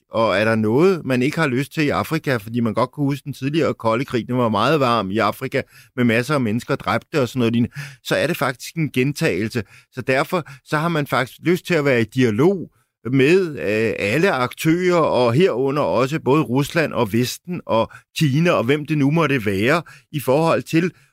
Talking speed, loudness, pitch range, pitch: 210 wpm, -19 LUFS, 120-155 Hz, 135 Hz